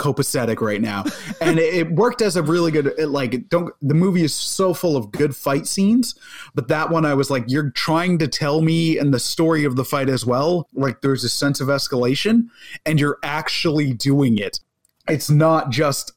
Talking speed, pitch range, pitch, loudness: 205 wpm, 140-165 Hz, 150 Hz, -19 LUFS